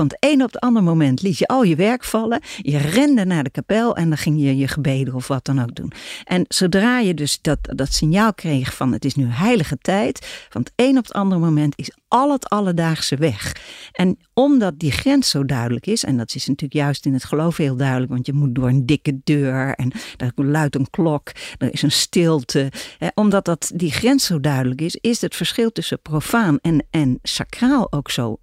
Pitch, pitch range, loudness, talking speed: 155 Hz, 135-200 Hz, -19 LUFS, 215 wpm